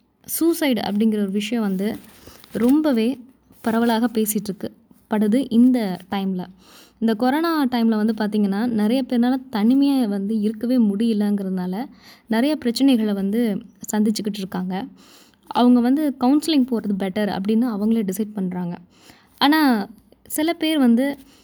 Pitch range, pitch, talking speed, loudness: 210-255 Hz, 225 Hz, 110 wpm, -20 LUFS